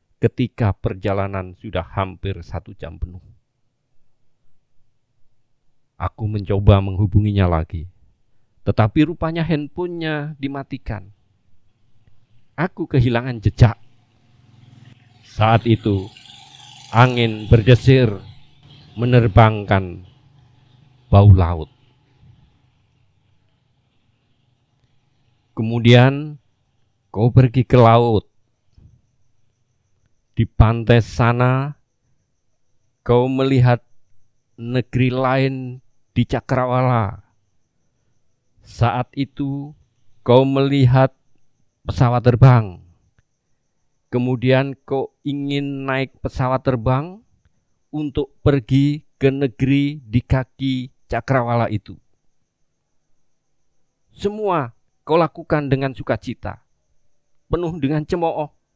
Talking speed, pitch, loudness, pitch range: 70 wpm, 120 Hz, -18 LUFS, 110-135 Hz